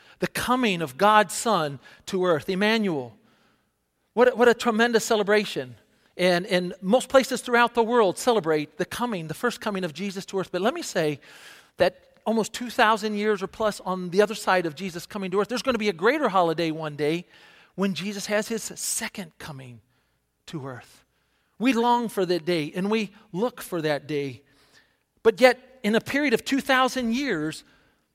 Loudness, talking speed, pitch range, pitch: -24 LUFS, 185 wpm, 175-230 Hz, 200 Hz